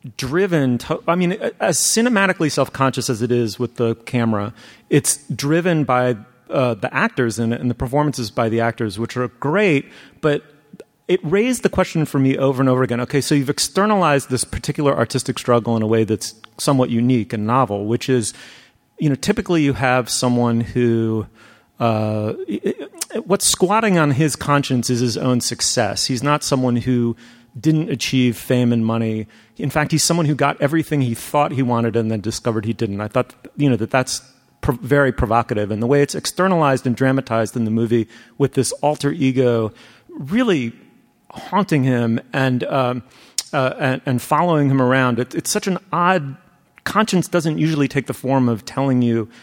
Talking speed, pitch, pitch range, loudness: 185 wpm, 130 Hz, 120-150 Hz, -19 LUFS